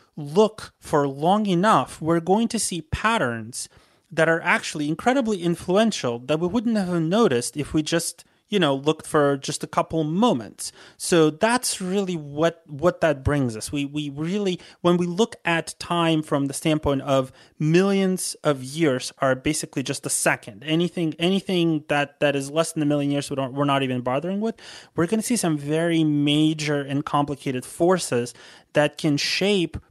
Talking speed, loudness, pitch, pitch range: 175 wpm, -23 LUFS, 160 Hz, 145-180 Hz